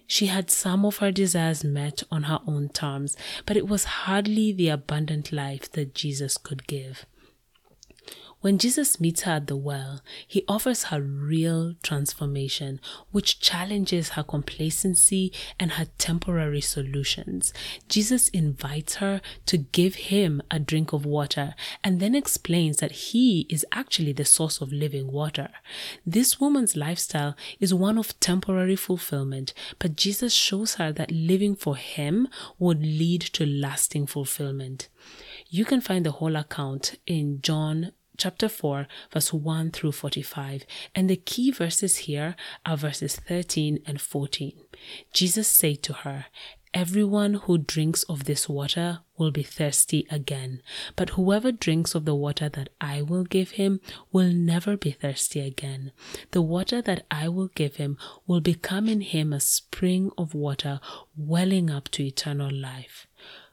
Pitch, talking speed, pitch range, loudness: 160 Hz, 150 wpm, 145-185 Hz, -25 LUFS